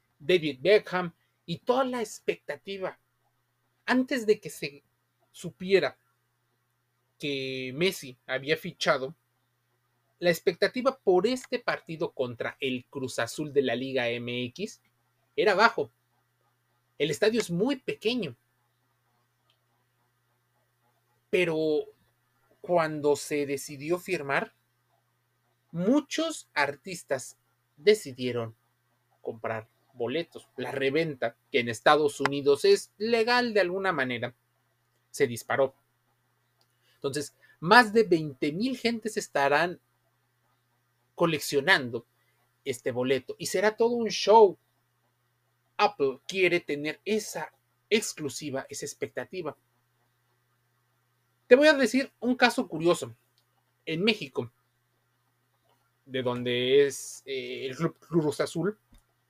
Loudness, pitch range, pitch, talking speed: -27 LUFS, 120-190 Hz, 145 Hz, 100 wpm